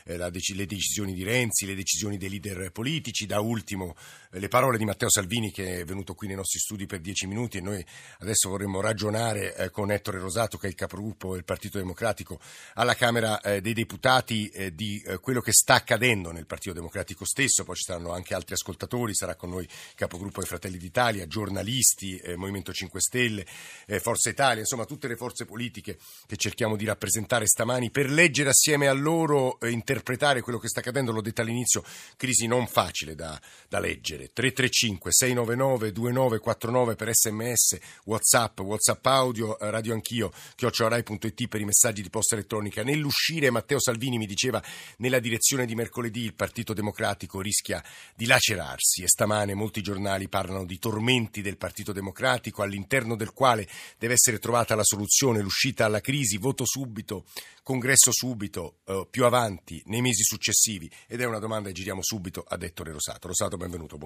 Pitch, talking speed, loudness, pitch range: 110 Hz, 170 wpm, -26 LUFS, 95-120 Hz